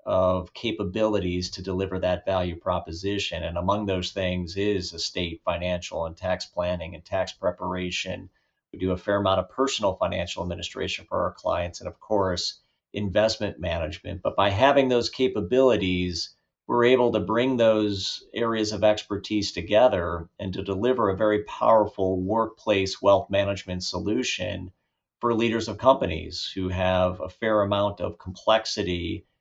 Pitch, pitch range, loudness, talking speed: 100 Hz, 90-110 Hz, -25 LUFS, 145 wpm